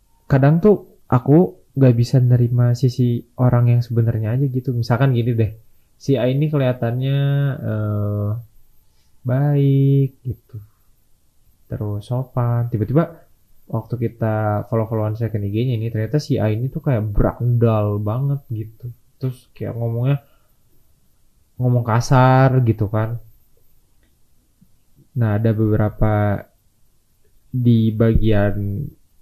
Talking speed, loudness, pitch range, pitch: 105 wpm, -19 LUFS, 110-130 Hz, 120 Hz